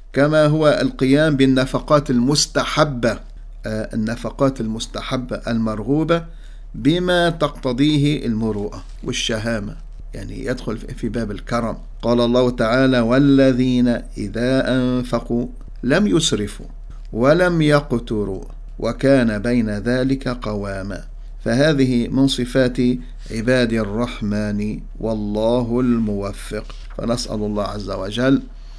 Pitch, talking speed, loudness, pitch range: 125 Hz, 90 wpm, -19 LUFS, 110-135 Hz